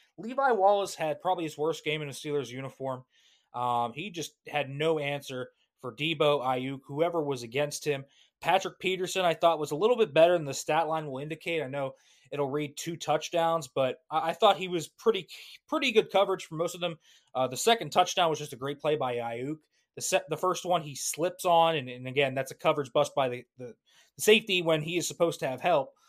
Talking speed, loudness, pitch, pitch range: 220 wpm, -29 LUFS, 155 Hz, 140-175 Hz